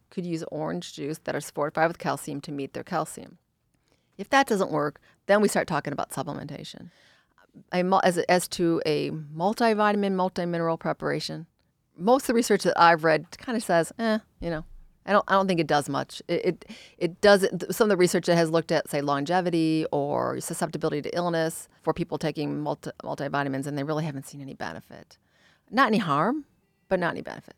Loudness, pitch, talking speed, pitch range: -26 LUFS, 170 Hz, 190 wpm, 155-195 Hz